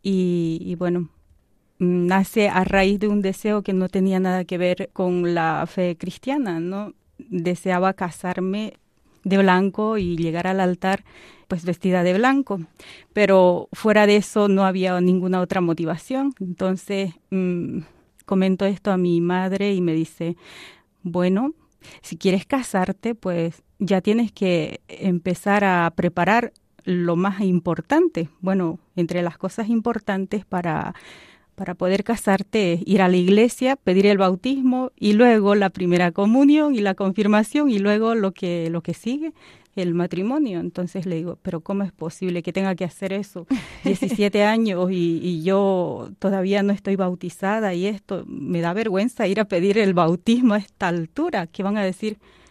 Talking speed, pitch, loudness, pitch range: 155 wpm, 190 Hz, -21 LUFS, 180-210 Hz